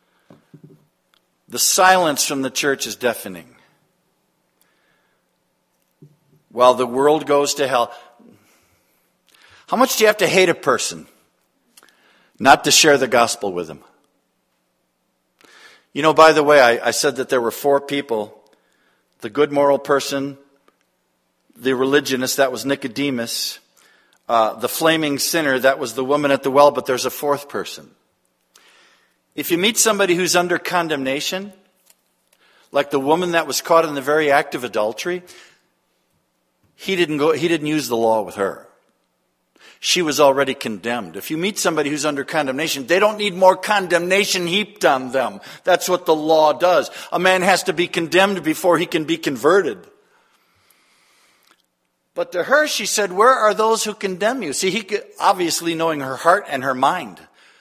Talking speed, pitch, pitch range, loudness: 160 wpm, 155 Hz, 140-185 Hz, -17 LUFS